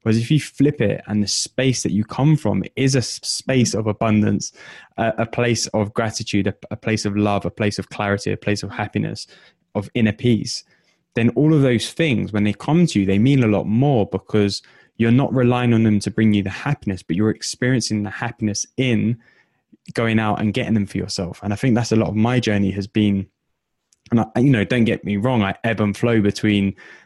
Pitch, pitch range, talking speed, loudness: 110 Hz, 105-120 Hz, 220 wpm, -20 LUFS